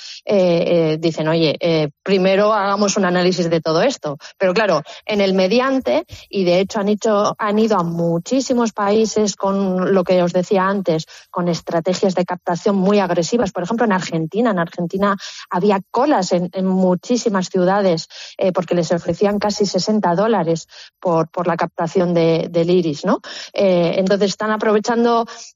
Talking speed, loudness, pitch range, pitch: 165 wpm, -17 LUFS, 175-210 Hz, 190 Hz